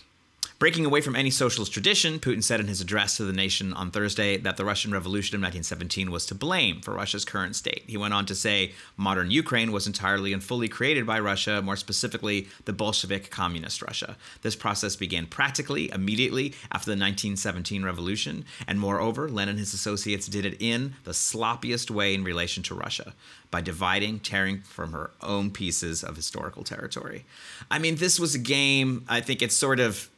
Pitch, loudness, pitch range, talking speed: 100 Hz, -26 LUFS, 95-115 Hz, 190 wpm